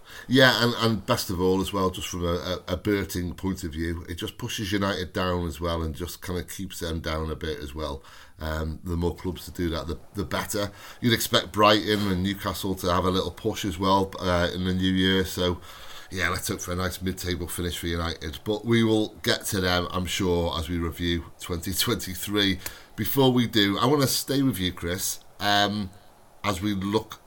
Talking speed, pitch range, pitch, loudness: 220 wpm, 85-105 Hz, 95 Hz, -26 LUFS